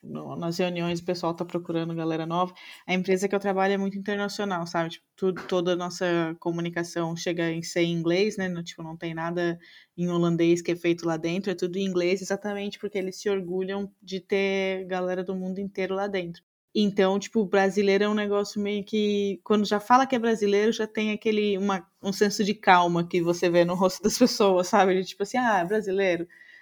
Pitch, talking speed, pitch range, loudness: 190 Hz, 210 wpm, 175-205 Hz, -26 LUFS